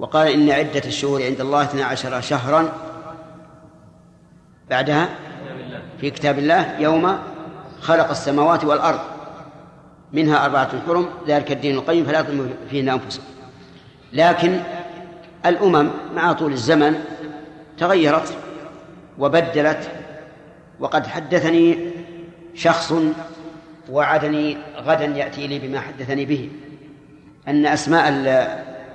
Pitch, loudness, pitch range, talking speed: 155 Hz, -19 LUFS, 145-165 Hz, 95 wpm